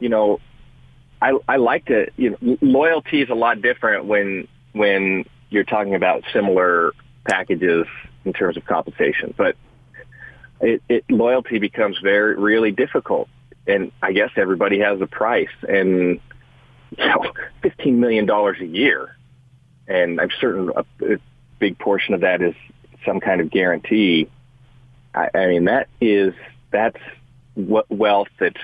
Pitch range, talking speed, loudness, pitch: 100-130 Hz, 145 wpm, -19 LUFS, 110 Hz